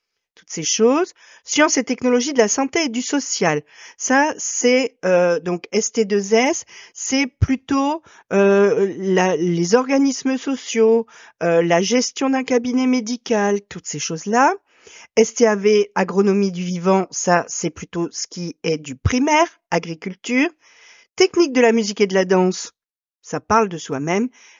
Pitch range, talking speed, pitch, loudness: 185-270 Hz, 140 wpm, 230 Hz, -19 LUFS